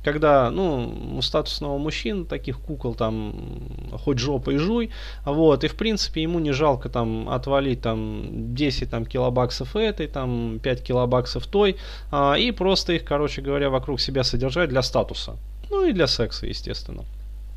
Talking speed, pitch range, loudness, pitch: 155 wpm, 120-155 Hz, -24 LUFS, 135 Hz